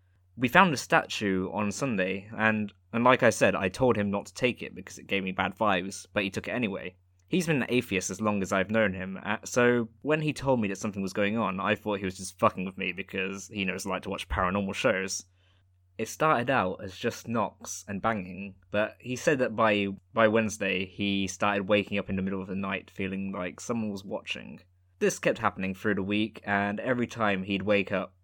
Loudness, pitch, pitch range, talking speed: -28 LUFS, 100 Hz, 95-110 Hz, 230 wpm